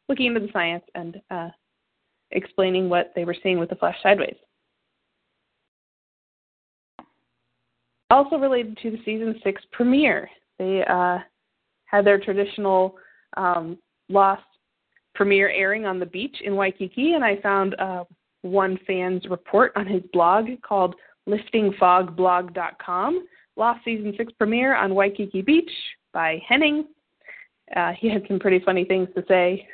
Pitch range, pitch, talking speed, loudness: 185-225 Hz, 195 Hz, 135 wpm, -22 LUFS